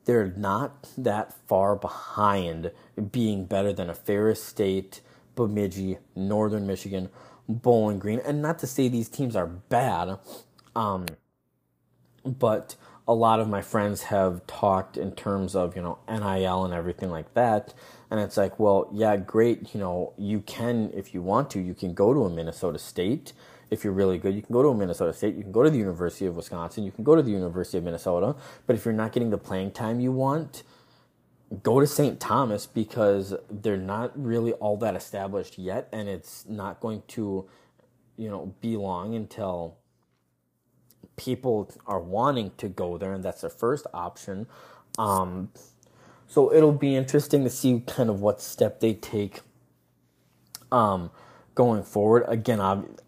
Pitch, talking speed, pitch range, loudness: 105 Hz, 170 wpm, 95-120 Hz, -26 LUFS